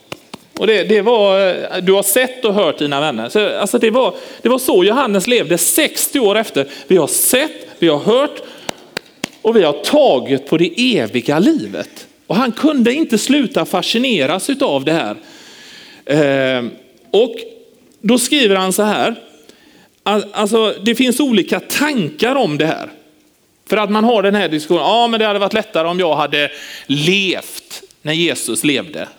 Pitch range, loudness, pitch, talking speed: 175-255 Hz, -14 LUFS, 210 Hz, 170 wpm